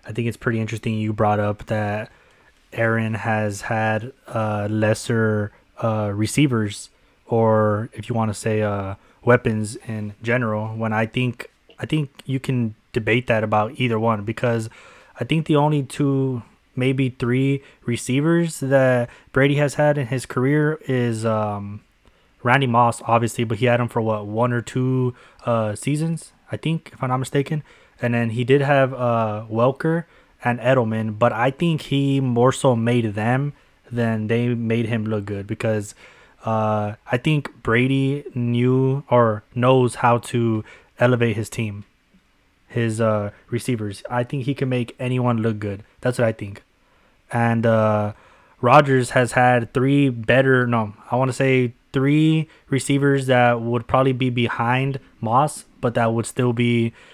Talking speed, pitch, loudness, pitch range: 160 wpm, 120 Hz, -21 LUFS, 110-130 Hz